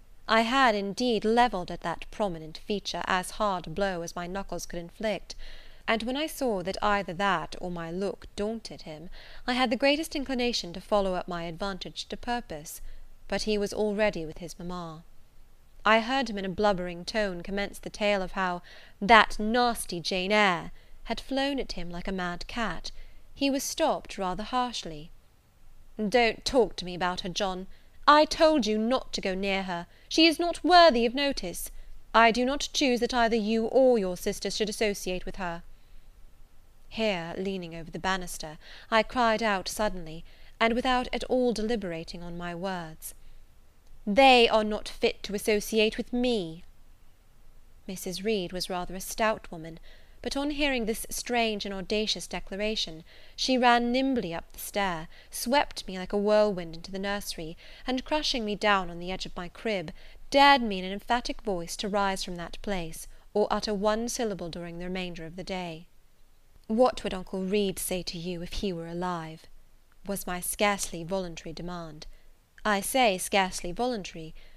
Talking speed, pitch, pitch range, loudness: 175 wpm, 200 Hz, 175-230 Hz, -28 LUFS